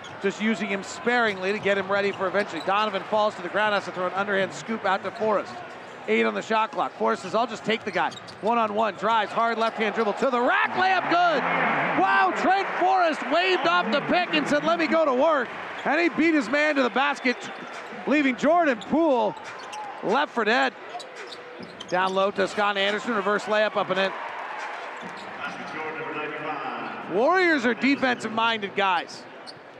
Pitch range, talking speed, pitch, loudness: 200-285 Hz, 185 wpm, 225 Hz, -24 LUFS